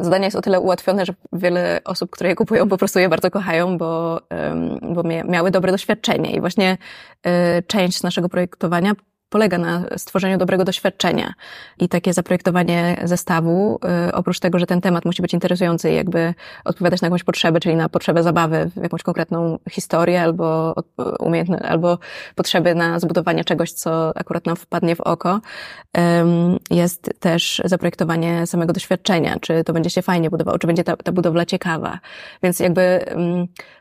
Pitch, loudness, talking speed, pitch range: 175 Hz, -19 LUFS, 155 wpm, 170-185 Hz